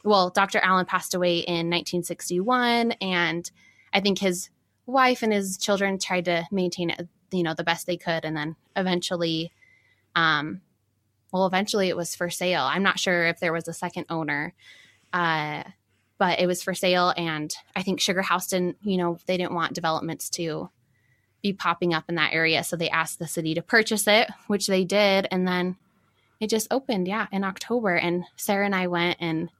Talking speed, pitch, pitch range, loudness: 190 wpm, 180 Hz, 170-195 Hz, -25 LUFS